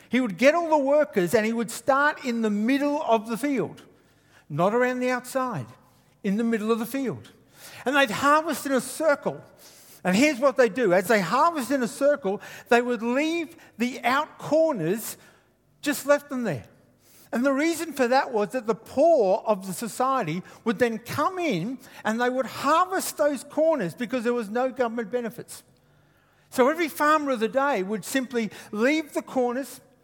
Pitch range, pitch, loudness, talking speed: 225-290 Hz, 255 Hz, -24 LUFS, 185 wpm